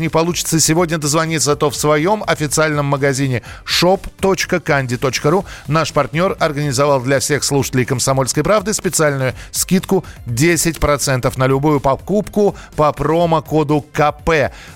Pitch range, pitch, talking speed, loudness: 140-165 Hz, 150 Hz, 110 wpm, -16 LUFS